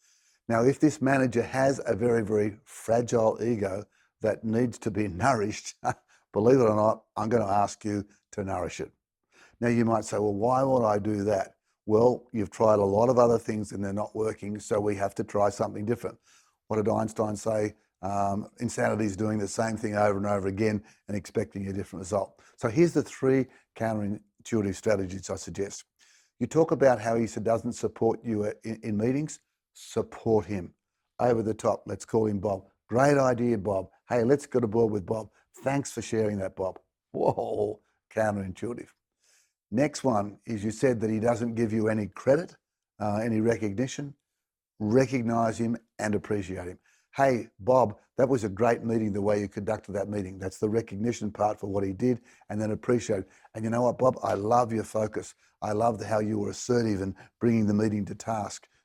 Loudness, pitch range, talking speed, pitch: -28 LUFS, 105-120 Hz, 190 wpm, 110 Hz